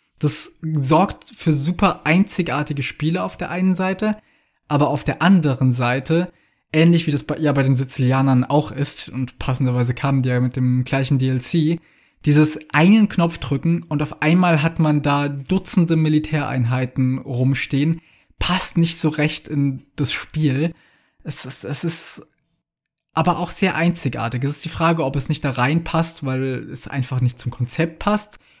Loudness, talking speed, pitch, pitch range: -19 LUFS, 165 wpm, 150 Hz, 135-165 Hz